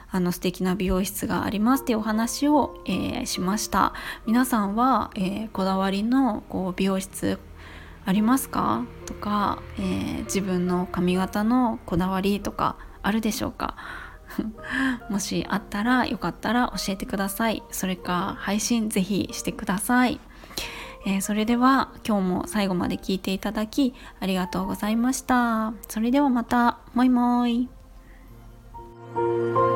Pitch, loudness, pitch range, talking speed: 205 Hz, -25 LUFS, 185-240 Hz, 290 characters per minute